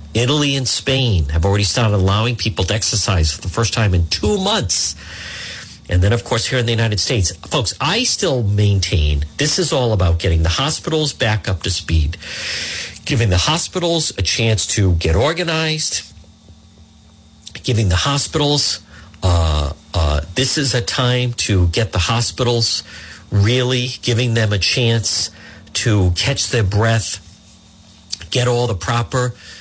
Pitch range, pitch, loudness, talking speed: 90-125 Hz, 105 Hz, -17 LUFS, 150 wpm